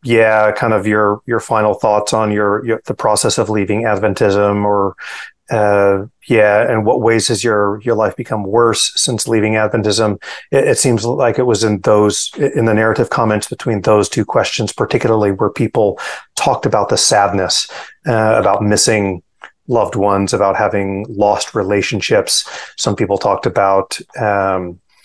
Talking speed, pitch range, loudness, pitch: 160 wpm, 100-110 Hz, -14 LUFS, 105 Hz